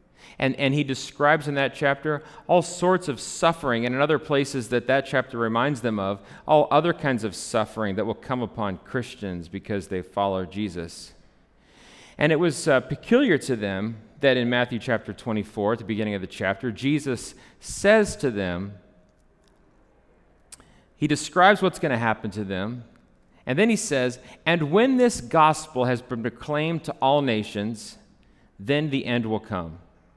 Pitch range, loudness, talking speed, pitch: 105-145 Hz, -24 LUFS, 165 wpm, 125 Hz